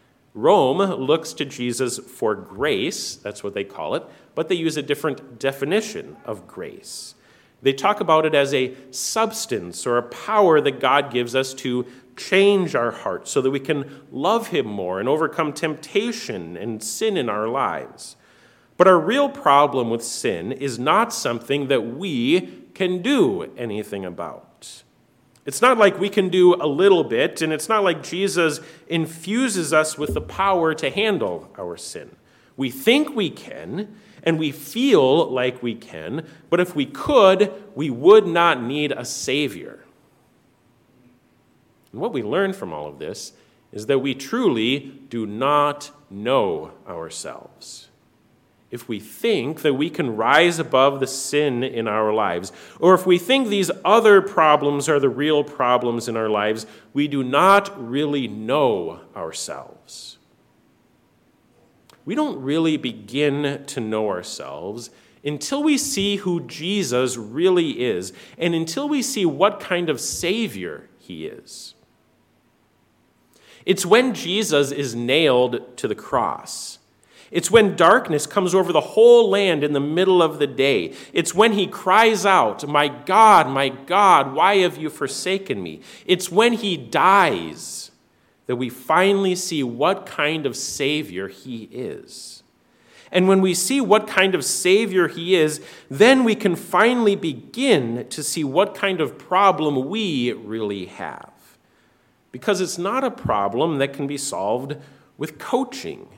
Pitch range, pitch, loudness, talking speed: 130-195 Hz, 155 Hz, -20 LUFS, 150 wpm